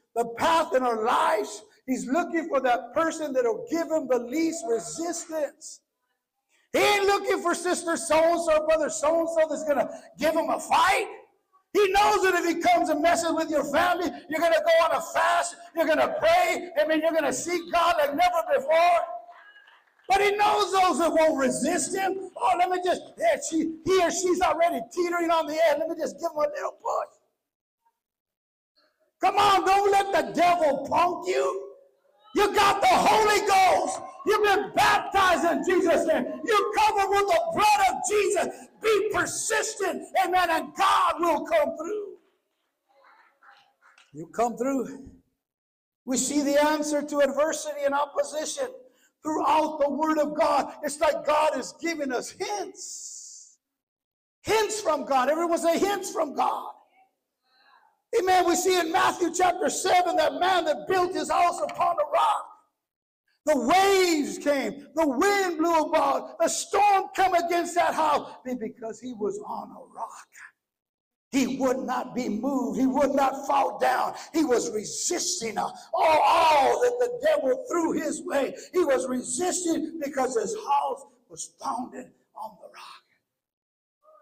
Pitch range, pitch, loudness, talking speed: 295-370 Hz, 330 Hz, -24 LUFS, 160 wpm